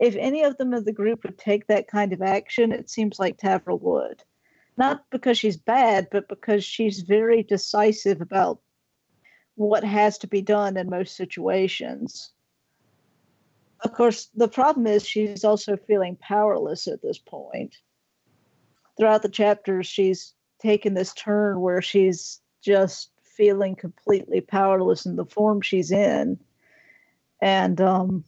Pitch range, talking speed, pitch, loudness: 190-225 Hz, 145 wpm, 205 Hz, -23 LUFS